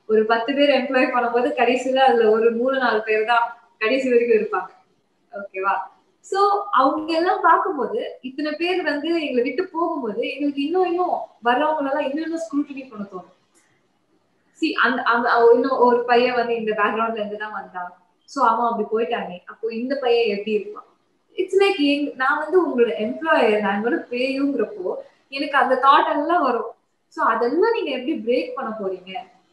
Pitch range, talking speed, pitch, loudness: 225-310 Hz, 140 wpm, 255 Hz, -20 LUFS